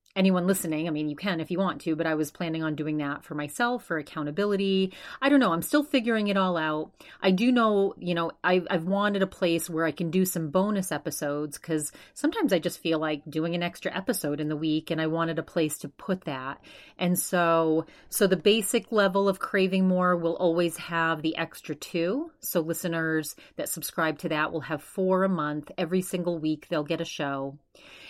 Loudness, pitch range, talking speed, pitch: -27 LUFS, 155-190 Hz, 215 wpm, 170 Hz